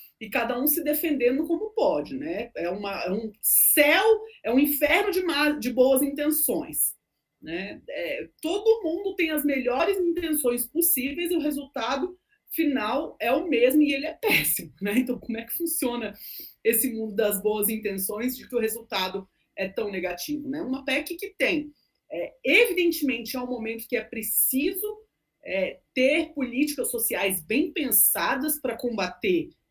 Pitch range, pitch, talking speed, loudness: 230-325 Hz, 275 Hz, 160 wpm, -24 LUFS